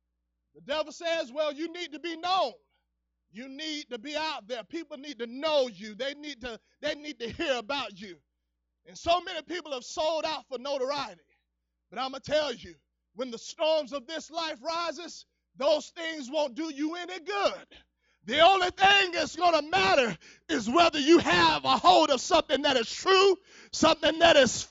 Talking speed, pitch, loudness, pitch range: 195 wpm, 305 Hz, -27 LUFS, 260-330 Hz